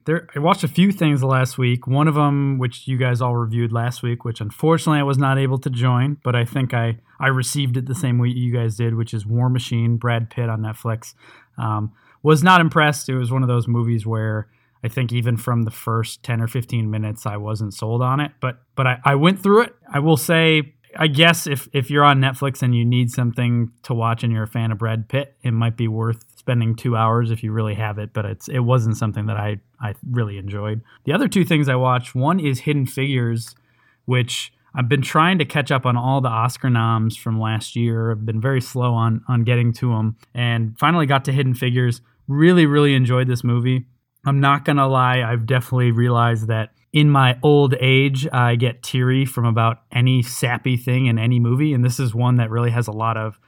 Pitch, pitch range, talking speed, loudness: 125 Hz, 115-135 Hz, 230 wpm, -19 LUFS